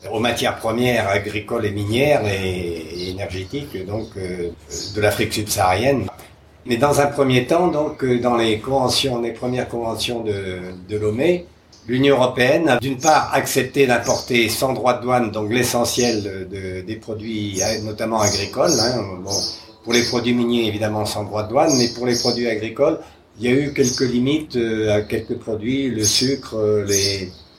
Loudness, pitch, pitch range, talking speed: -19 LUFS, 115 Hz, 105-125 Hz, 160 wpm